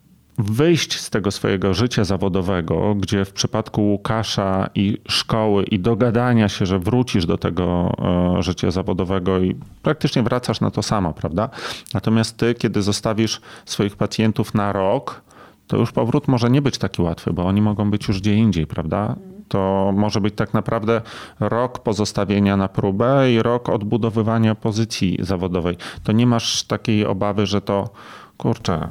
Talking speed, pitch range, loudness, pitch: 155 wpm, 95-115 Hz, -20 LUFS, 105 Hz